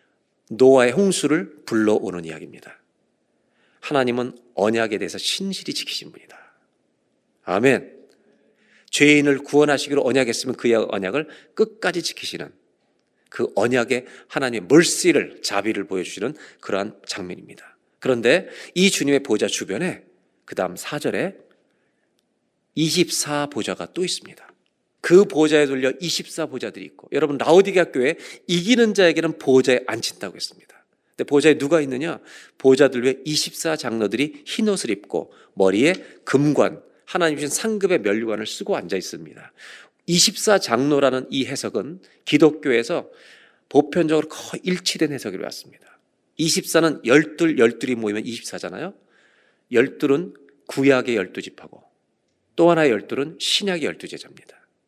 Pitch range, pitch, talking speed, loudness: 125-170 Hz, 145 Hz, 290 characters per minute, -20 LUFS